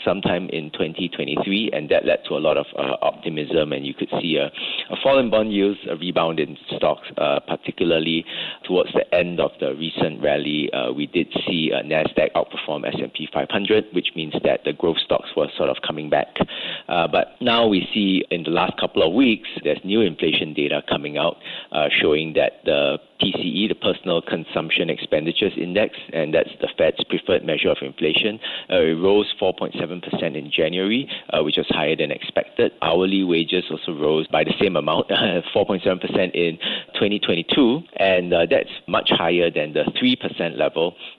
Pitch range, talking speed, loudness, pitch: 80-100 Hz, 180 wpm, -21 LUFS, 90 Hz